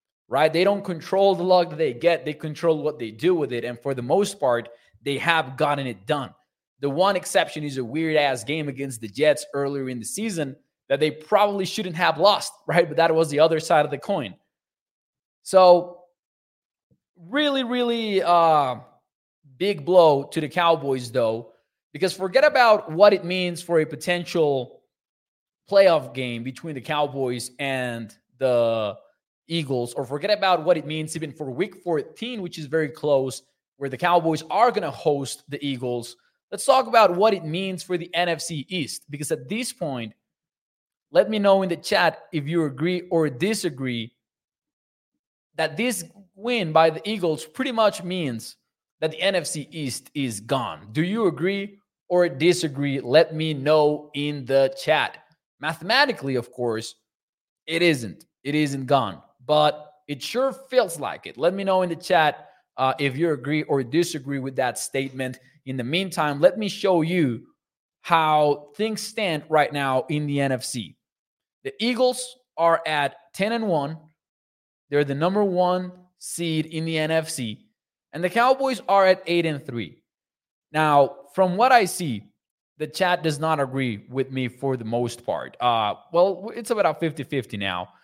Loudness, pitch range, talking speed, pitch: -23 LUFS, 140-180 Hz, 170 wpm, 160 Hz